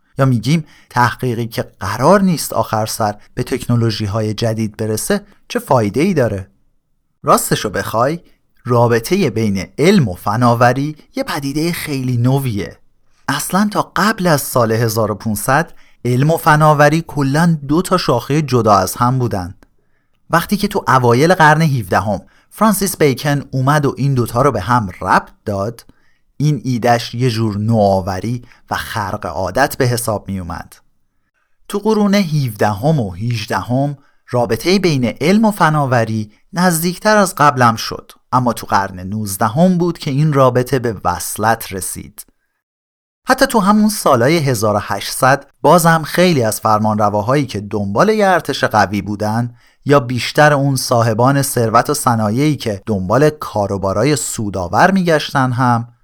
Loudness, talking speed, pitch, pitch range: -15 LUFS, 140 wpm, 125 Hz, 110-150 Hz